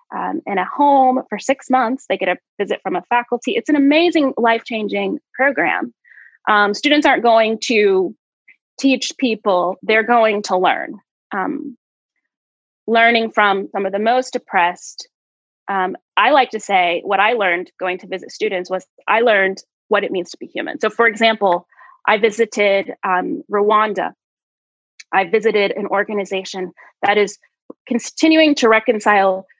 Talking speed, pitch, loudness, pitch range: 150 wpm, 220 Hz, -17 LUFS, 195-255 Hz